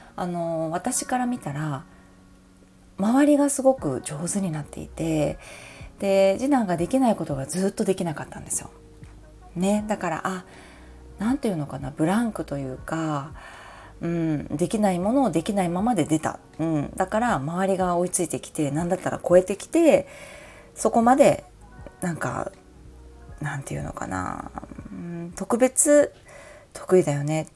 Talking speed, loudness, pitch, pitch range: 305 characters per minute, -24 LUFS, 175 Hz, 150-215 Hz